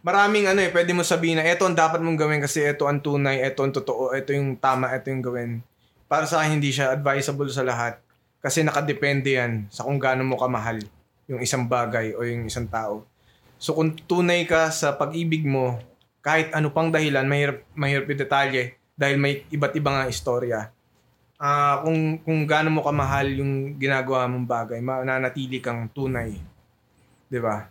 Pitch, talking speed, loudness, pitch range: 135 Hz, 180 wpm, -23 LUFS, 125-150 Hz